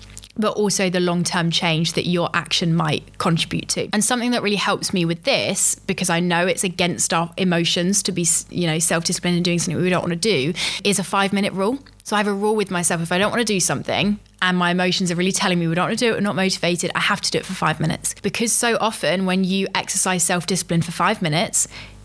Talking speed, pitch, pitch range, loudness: 250 wpm, 180 Hz, 170-200 Hz, -19 LUFS